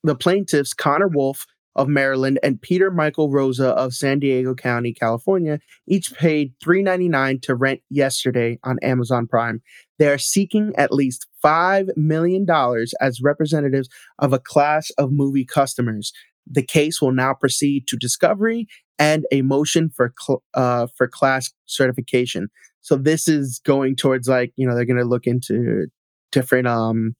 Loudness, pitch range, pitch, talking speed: -19 LUFS, 125-155 Hz, 135 Hz, 155 wpm